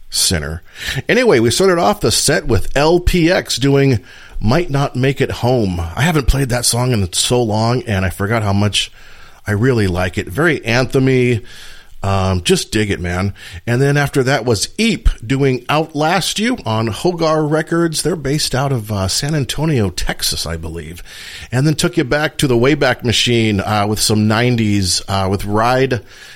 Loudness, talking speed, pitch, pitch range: -15 LUFS, 175 wpm, 120 Hz, 100-140 Hz